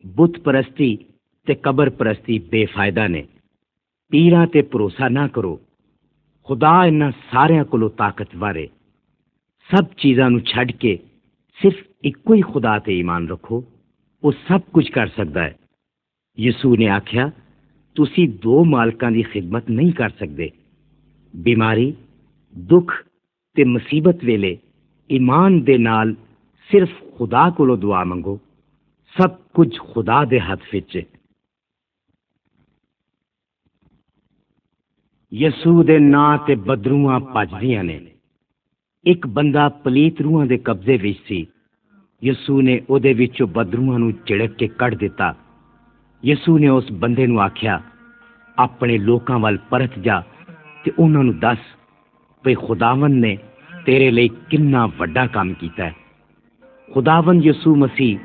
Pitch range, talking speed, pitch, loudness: 110-150 Hz, 125 wpm, 125 Hz, -17 LUFS